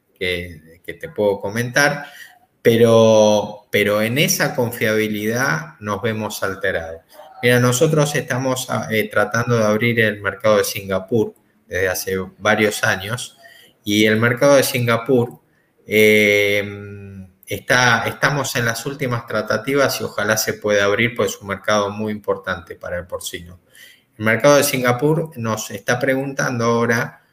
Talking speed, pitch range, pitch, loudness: 135 wpm, 105-125 Hz, 115 Hz, -18 LUFS